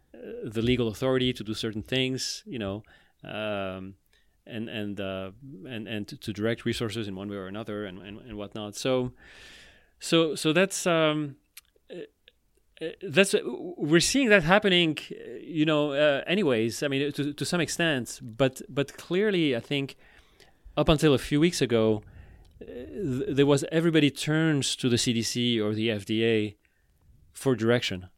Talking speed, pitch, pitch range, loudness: 150 wpm, 125 Hz, 110-150 Hz, -26 LUFS